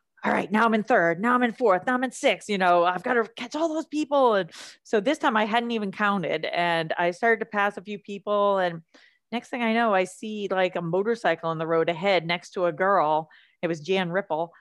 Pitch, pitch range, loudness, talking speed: 200 Hz, 175-235 Hz, -24 LUFS, 250 wpm